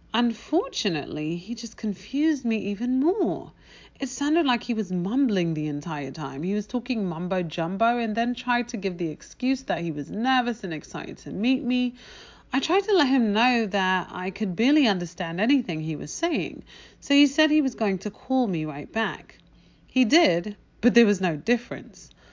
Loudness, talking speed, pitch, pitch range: -25 LUFS, 190 wpm, 230 Hz, 185-260 Hz